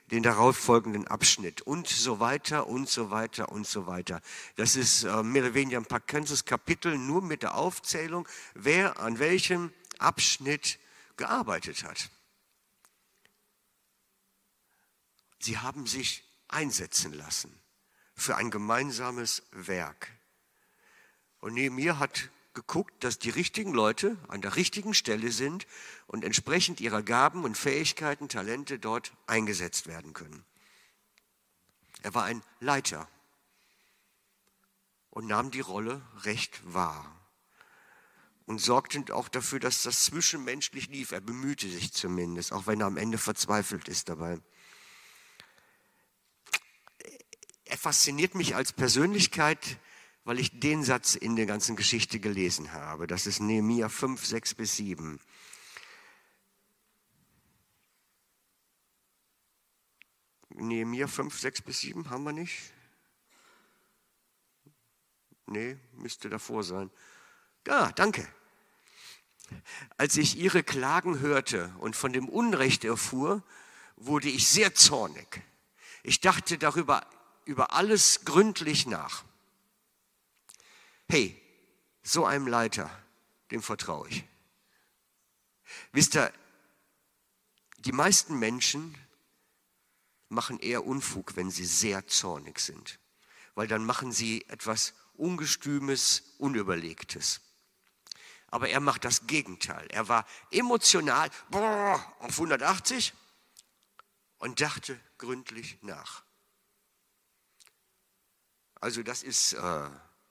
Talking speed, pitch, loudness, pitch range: 105 wpm, 120 Hz, -28 LUFS, 105-145 Hz